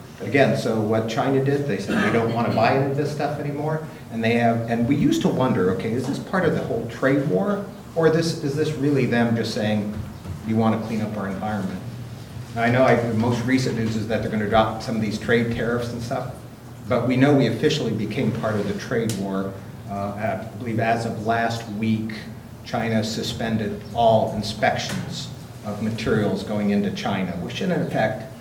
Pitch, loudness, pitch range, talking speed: 115 Hz, -23 LUFS, 110-130 Hz, 210 wpm